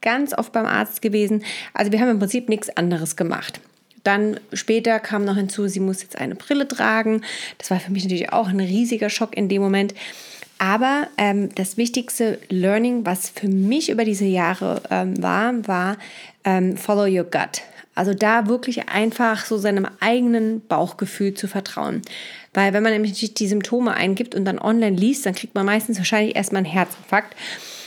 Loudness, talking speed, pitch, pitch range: -21 LUFS, 180 wpm, 210 Hz, 195-225 Hz